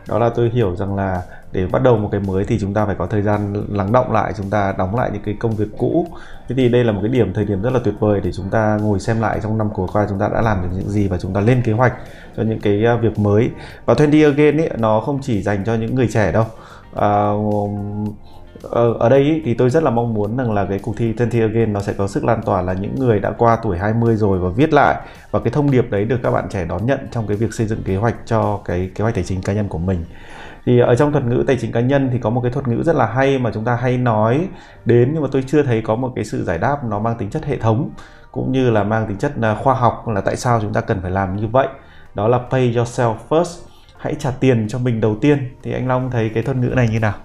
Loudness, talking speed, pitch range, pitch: -18 LUFS, 290 wpm, 105-125 Hz, 115 Hz